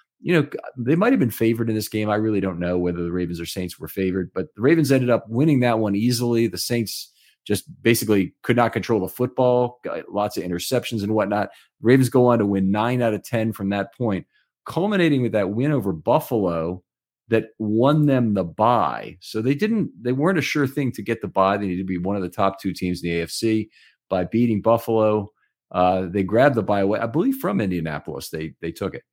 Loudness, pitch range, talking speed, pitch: -22 LUFS, 95-120 Hz, 225 wpm, 110 Hz